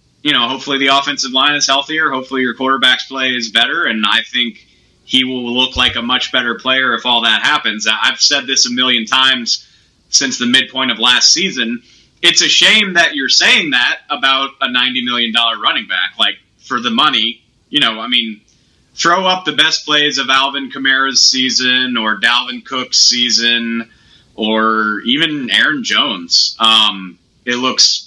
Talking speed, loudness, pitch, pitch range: 175 wpm, -12 LUFS, 125 Hz, 115-135 Hz